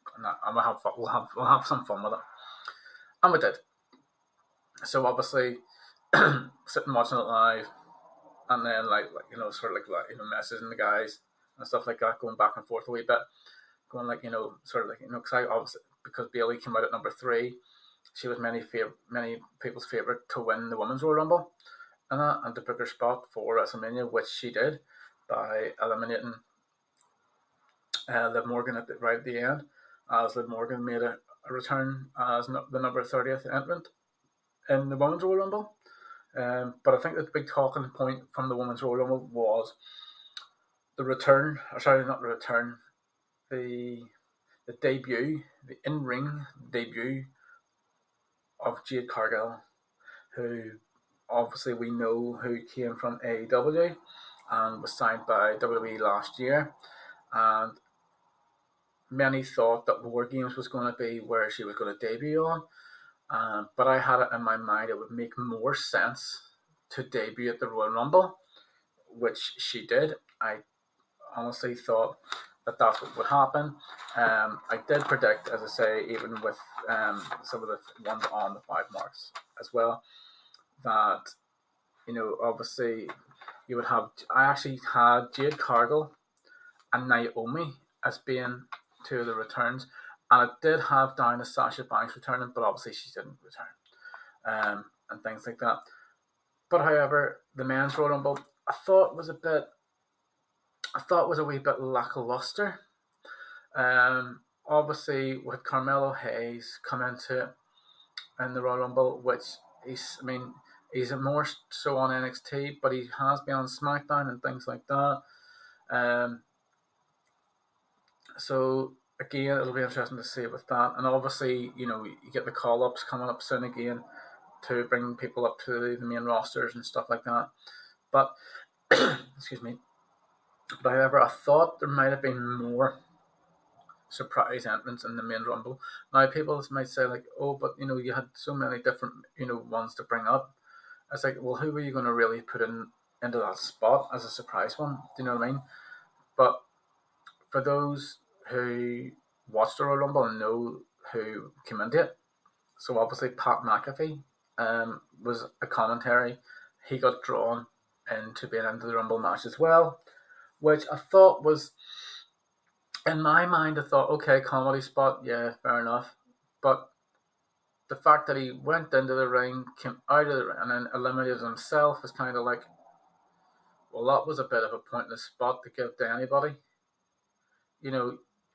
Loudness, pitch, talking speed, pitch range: -29 LUFS, 130 Hz, 170 wpm, 120-145 Hz